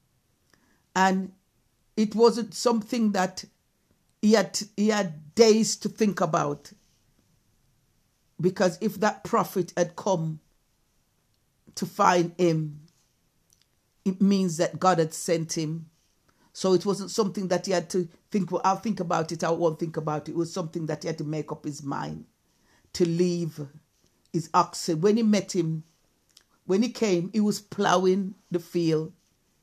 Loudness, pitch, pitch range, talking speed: -26 LUFS, 180 Hz, 160-200 Hz, 150 wpm